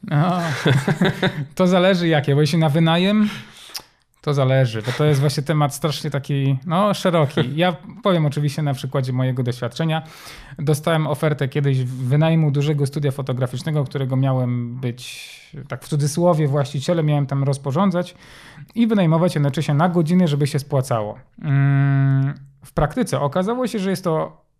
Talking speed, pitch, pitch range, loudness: 140 wpm, 150 Hz, 135-165 Hz, -20 LUFS